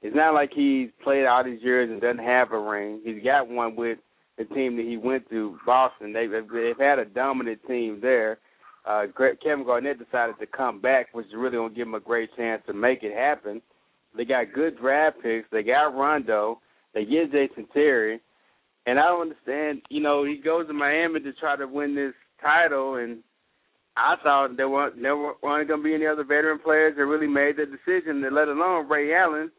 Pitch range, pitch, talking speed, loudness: 115-150 Hz, 135 Hz, 210 wpm, -24 LUFS